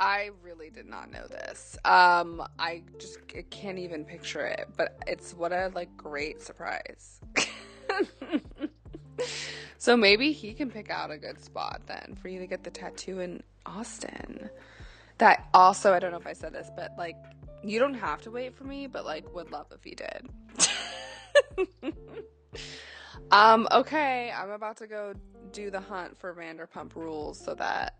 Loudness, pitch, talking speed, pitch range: -27 LUFS, 200 Hz, 165 wpm, 175-250 Hz